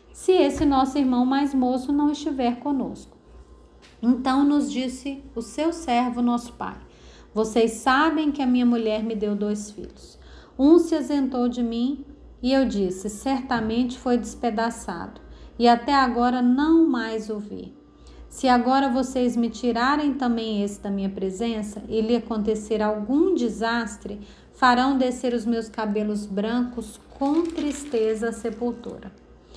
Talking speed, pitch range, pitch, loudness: 140 wpm, 225-270 Hz, 245 Hz, -23 LUFS